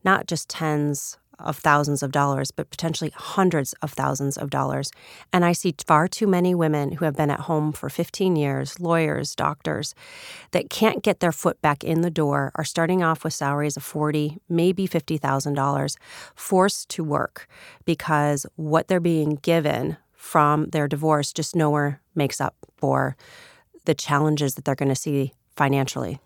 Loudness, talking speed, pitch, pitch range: -23 LUFS, 170 wpm, 155 Hz, 145-170 Hz